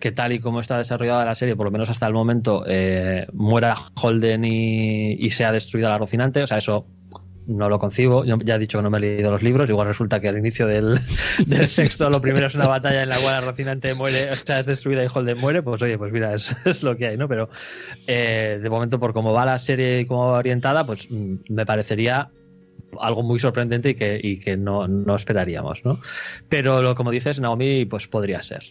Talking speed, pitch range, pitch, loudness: 235 wpm, 105-130 Hz, 115 Hz, -21 LUFS